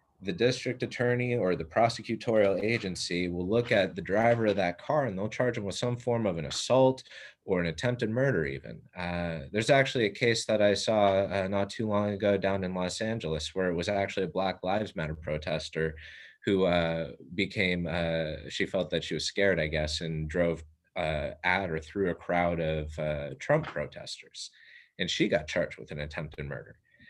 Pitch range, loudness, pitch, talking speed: 80-110 Hz, -29 LUFS, 95 Hz, 195 wpm